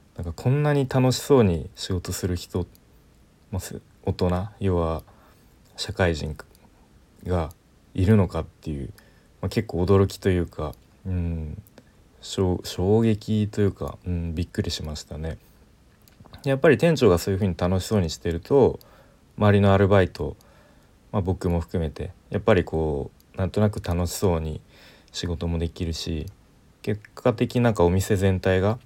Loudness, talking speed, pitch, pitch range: -24 LUFS, 245 characters per minute, 95 Hz, 85-105 Hz